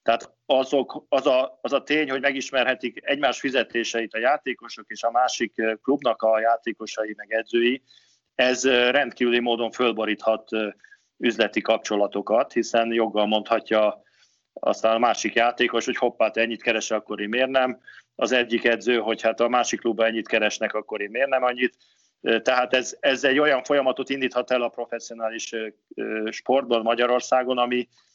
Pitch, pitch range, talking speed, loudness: 120 Hz, 110-125 Hz, 150 wpm, -23 LUFS